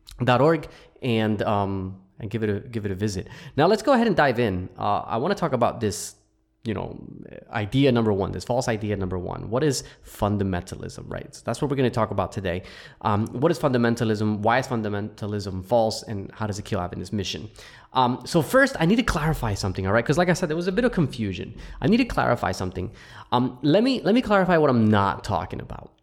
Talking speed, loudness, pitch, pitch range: 230 wpm, -24 LUFS, 115 Hz, 100-140 Hz